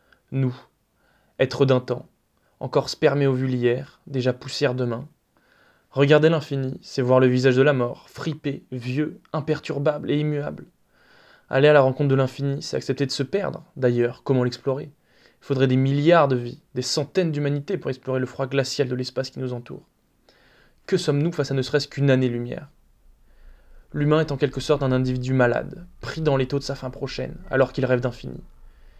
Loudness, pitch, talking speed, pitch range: -23 LUFS, 135 Hz, 180 wpm, 130-150 Hz